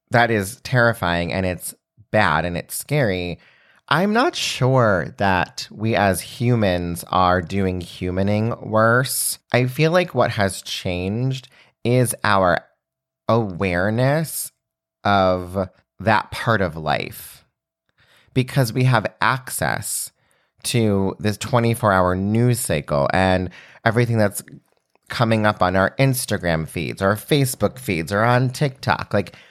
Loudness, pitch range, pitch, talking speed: -20 LUFS, 95-120 Hz, 105 Hz, 120 wpm